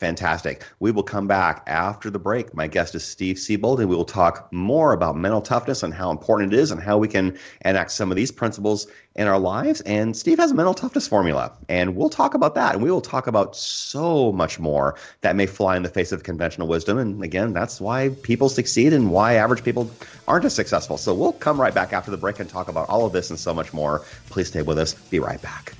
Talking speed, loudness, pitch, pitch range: 245 wpm, -22 LUFS, 100 Hz, 90-115 Hz